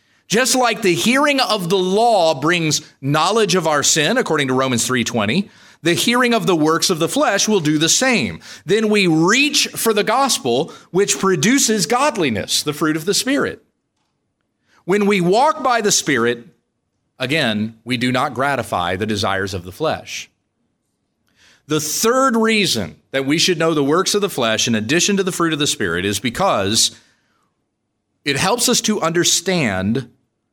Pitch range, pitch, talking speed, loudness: 135-215 Hz, 175 Hz, 165 wpm, -16 LUFS